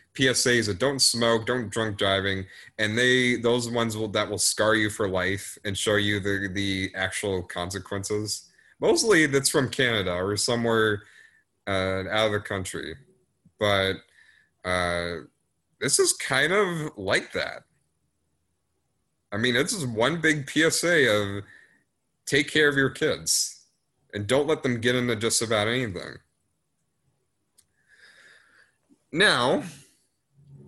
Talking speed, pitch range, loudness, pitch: 130 wpm, 100-125 Hz, -24 LUFS, 105 Hz